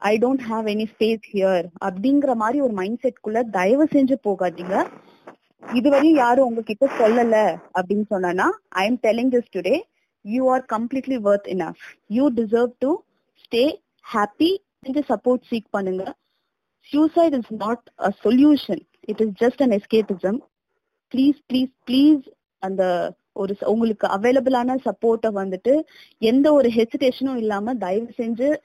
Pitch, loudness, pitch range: 235 Hz, -21 LUFS, 210-270 Hz